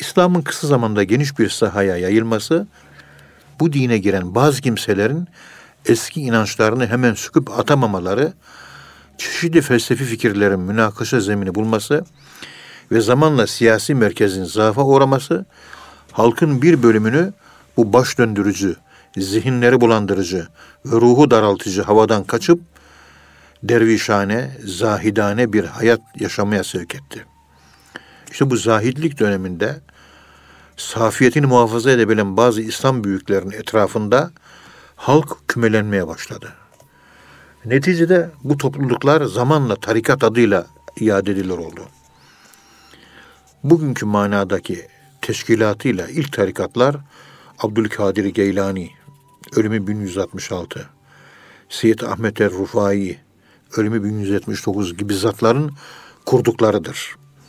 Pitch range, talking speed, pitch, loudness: 100-135 Hz, 95 wpm, 115 Hz, -17 LUFS